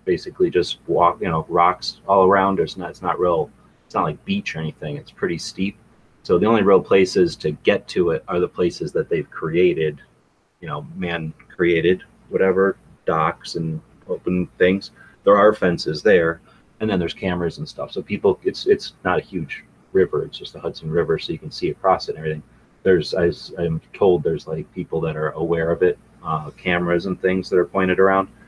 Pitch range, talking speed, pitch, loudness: 85-115 Hz, 190 wpm, 90 Hz, -20 LUFS